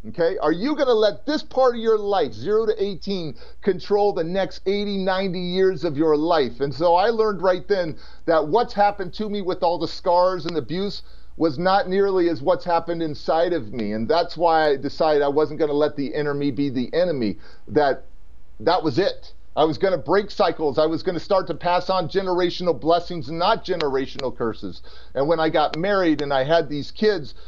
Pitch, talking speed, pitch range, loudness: 175 Hz, 215 wpm, 150-195 Hz, -22 LUFS